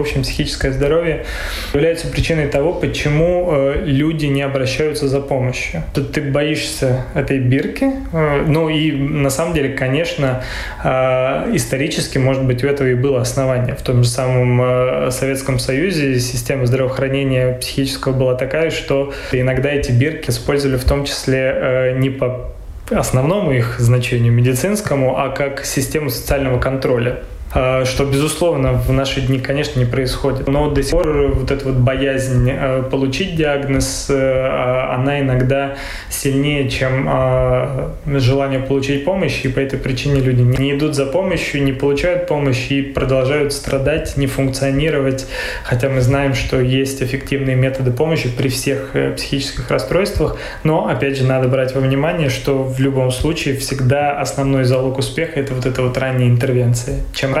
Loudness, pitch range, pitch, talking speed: -17 LUFS, 130-140 Hz, 135 Hz, 145 wpm